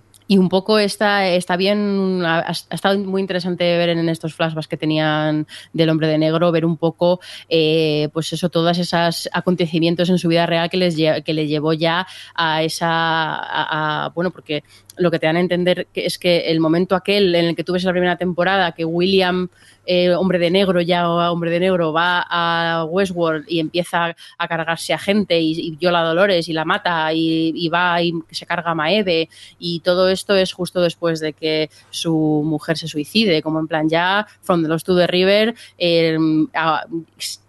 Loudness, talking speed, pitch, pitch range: -18 LUFS, 195 wpm, 170 Hz, 160-180 Hz